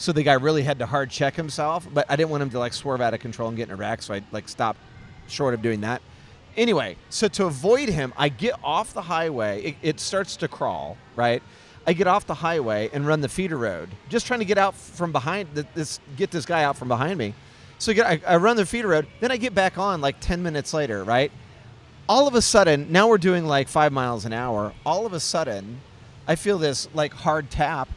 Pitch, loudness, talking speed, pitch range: 145 Hz, -23 LUFS, 245 wpm, 120-180 Hz